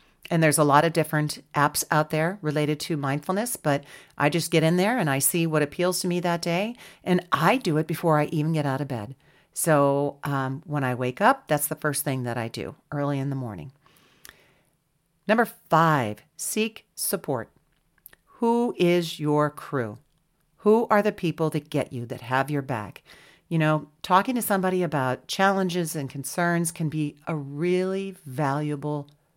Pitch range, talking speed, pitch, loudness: 145-175 Hz, 180 wpm, 155 Hz, -25 LUFS